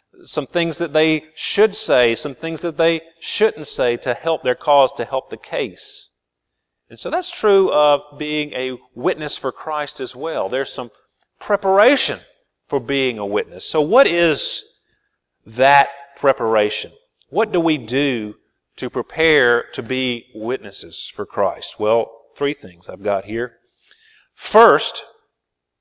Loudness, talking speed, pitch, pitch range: -18 LUFS, 145 wpm, 140 Hz, 120-165 Hz